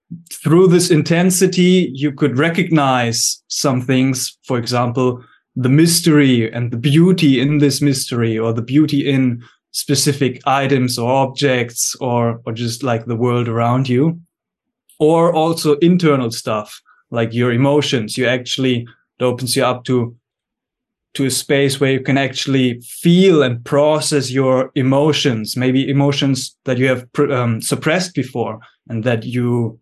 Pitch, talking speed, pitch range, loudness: 130 Hz, 145 wpm, 120-150 Hz, -16 LUFS